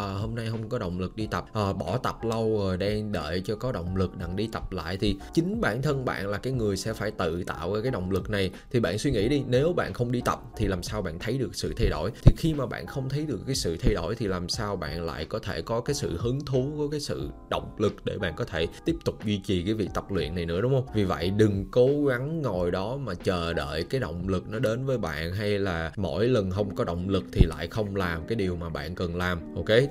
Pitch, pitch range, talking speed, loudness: 105 Hz, 90-125 Hz, 280 wpm, -28 LUFS